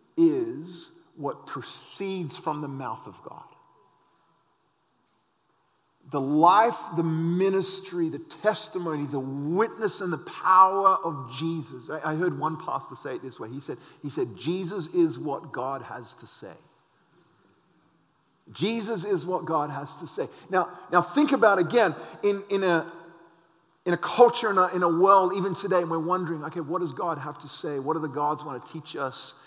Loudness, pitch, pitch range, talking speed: -26 LUFS, 170 Hz, 155-190 Hz, 170 wpm